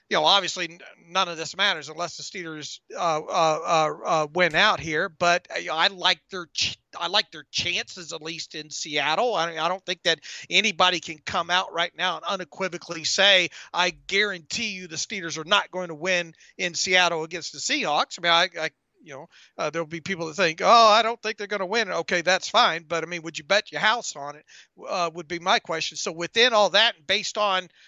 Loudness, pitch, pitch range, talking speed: -23 LUFS, 175 Hz, 165-195 Hz, 225 wpm